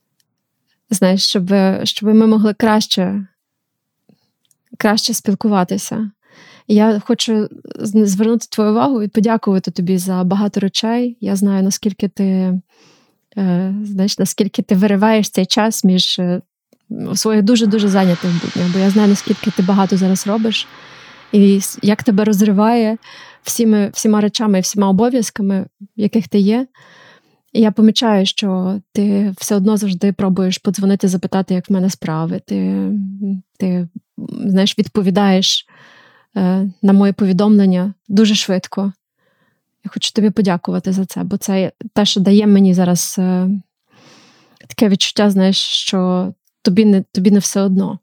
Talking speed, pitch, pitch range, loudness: 130 wpm, 200 Hz, 190-215 Hz, -15 LUFS